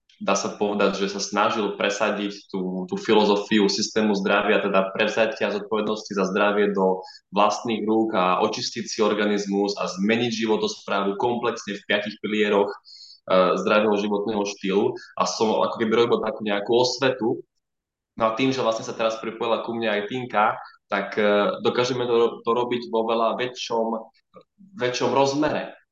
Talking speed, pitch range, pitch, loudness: 155 wpm, 100-115 Hz, 105 Hz, -23 LUFS